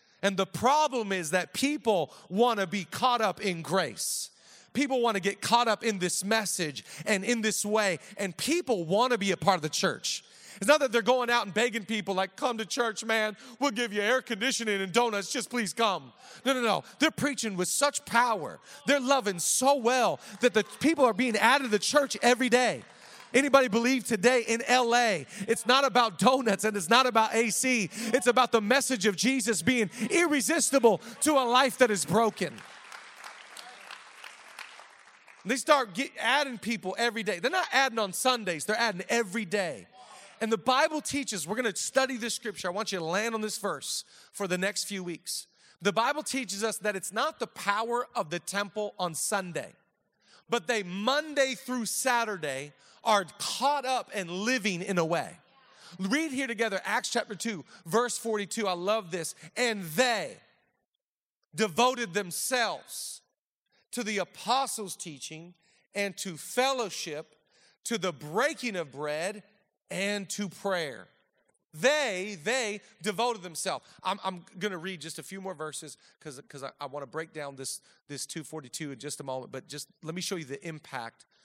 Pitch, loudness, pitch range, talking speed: 215 Hz, -28 LUFS, 185-245 Hz, 180 wpm